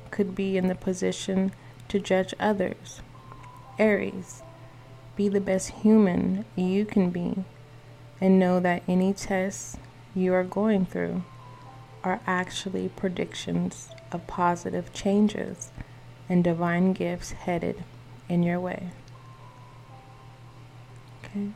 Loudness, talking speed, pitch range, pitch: -27 LUFS, 110 wpm, 130-190 Hz, 175 Hz